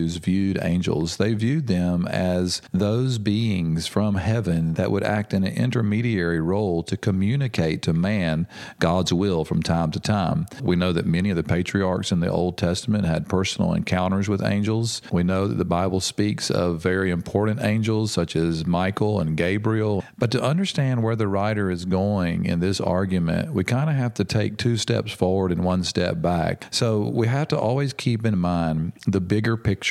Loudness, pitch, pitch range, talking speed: -23 LUFS, 95 Hz, 90-110 Hz, 185 wpm